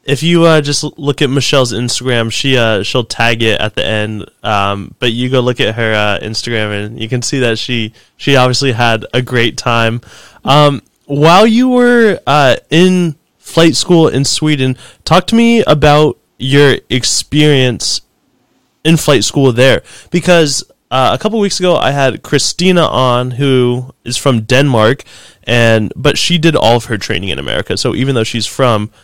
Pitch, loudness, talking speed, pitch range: 130 Hz, -11 LUFS, 180 wpm, 115-150 Hz